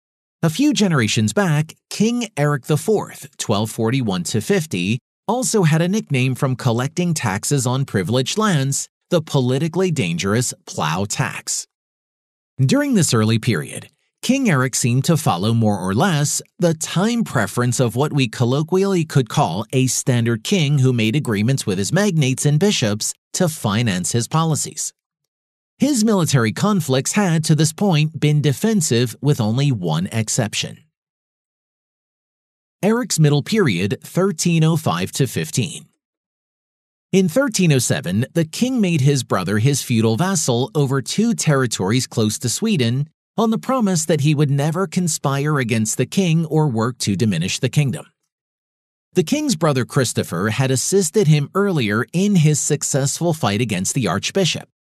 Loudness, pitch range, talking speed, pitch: -18 LUFS, 125-180 Hz, 135 wpm, 145 Hz